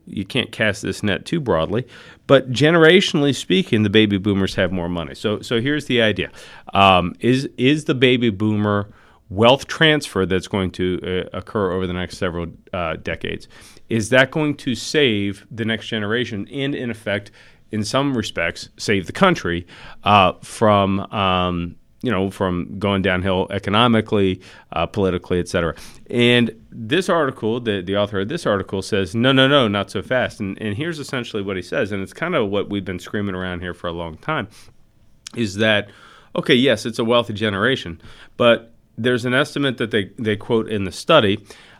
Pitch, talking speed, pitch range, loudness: 105 Hz, 180 wpm, 95-120 Hz, -19 LUFS